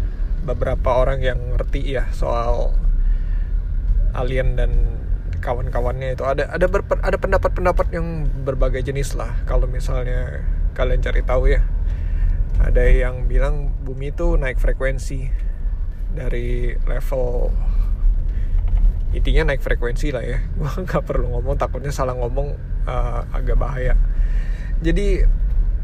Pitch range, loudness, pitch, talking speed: 80-130 Hz, -23 LUFS, 90 Hz, 115 wpm